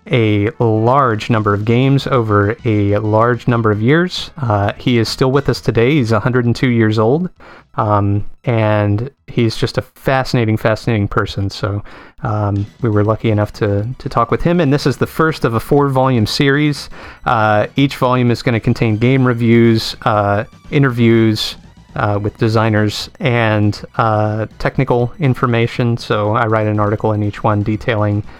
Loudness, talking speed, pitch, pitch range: -15 LUFS, 165 wpm, 115 Hz, 105-130 Hz